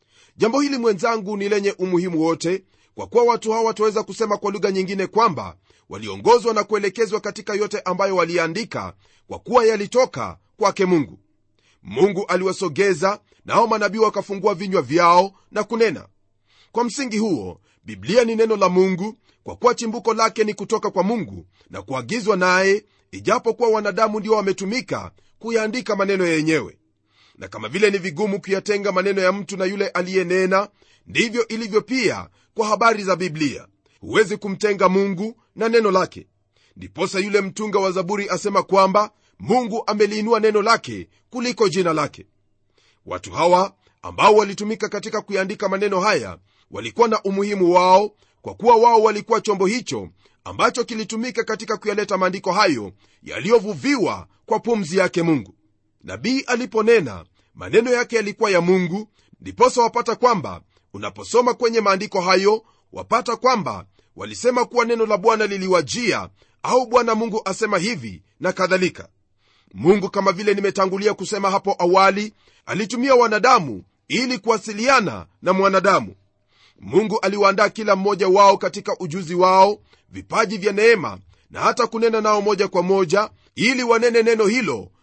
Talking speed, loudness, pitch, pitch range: 140 wpm, -19 LUFS, 205 Hz, 185-225 Hz